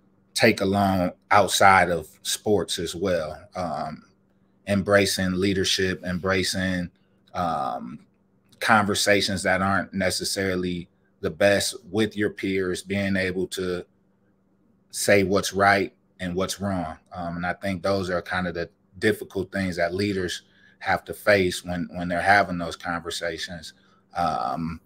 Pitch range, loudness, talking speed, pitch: 90-100 Hz, -24 LUFS, 130 wpm, 95 Hz